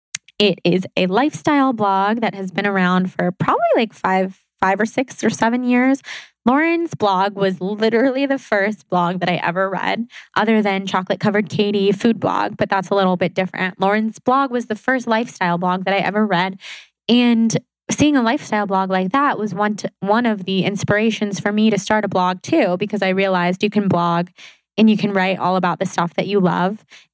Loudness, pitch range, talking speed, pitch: -18 LUFS, 185-220 Hz, 205 wpm, 200 Hz